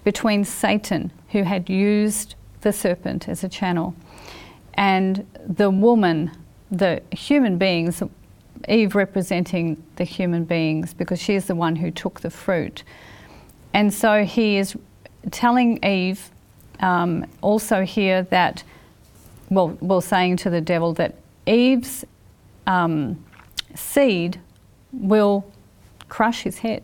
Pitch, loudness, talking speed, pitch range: 190 Hz, -21 LUFS, 120 wpm, 175-210 Hz